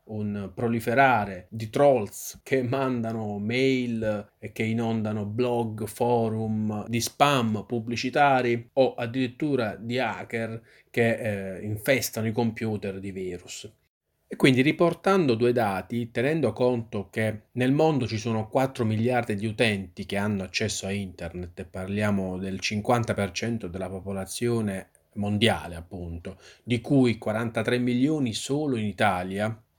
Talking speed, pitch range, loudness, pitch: 125 wpm, 100-120 Hz, -26 LUFS, 110 Hz